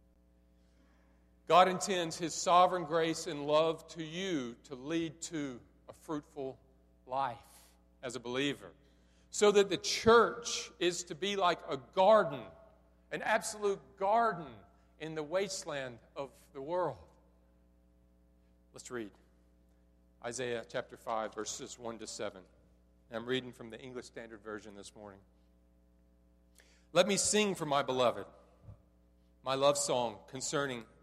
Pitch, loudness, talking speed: 120 Hz, -33 LUFS, 125 wpm